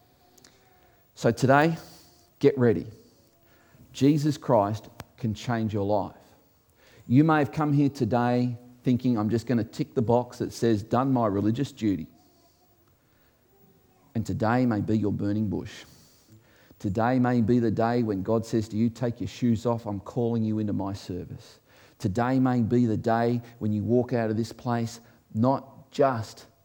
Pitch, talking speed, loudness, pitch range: 115 Hz, 160 wpm, -26 LUFS, 110-125 Hz